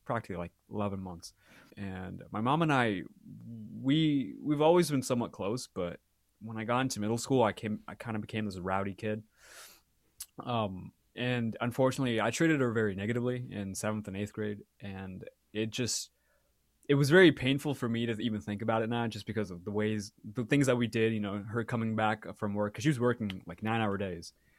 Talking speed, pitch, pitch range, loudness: 205 wpm, 110 Hz, 105-125 Hz, -32 LUFS